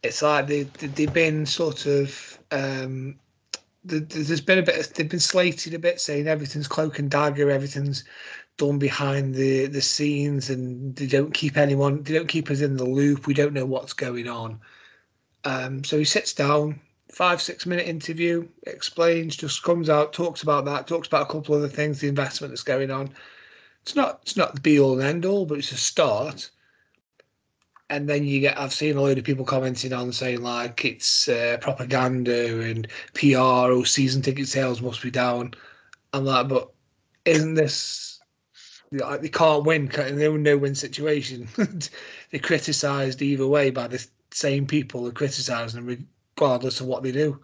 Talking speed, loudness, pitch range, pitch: 180 wpm, -23 LUFS, 130-150 Hz, 140 Hz